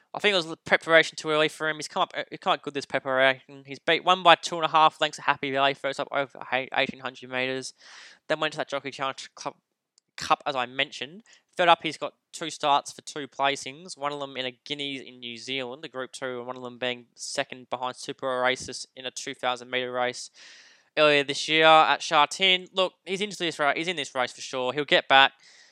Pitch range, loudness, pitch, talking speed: 130-160 Hz, -25 LUFS, 140 Hz, 235 wpm